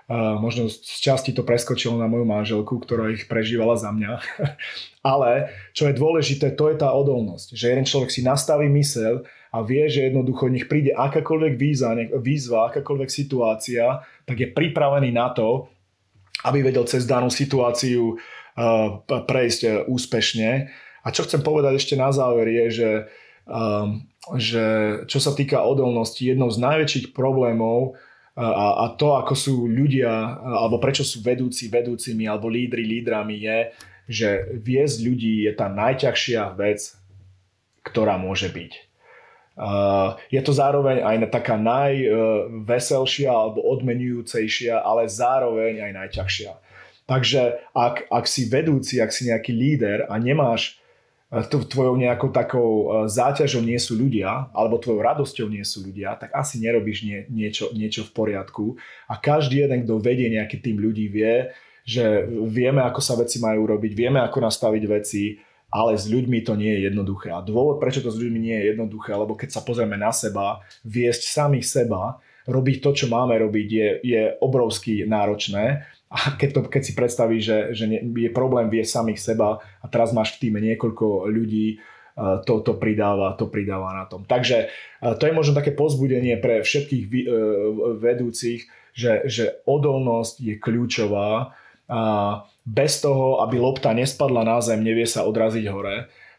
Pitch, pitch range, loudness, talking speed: 115 Hz, 110-130 Hz, -22 LUFS, 155 wpm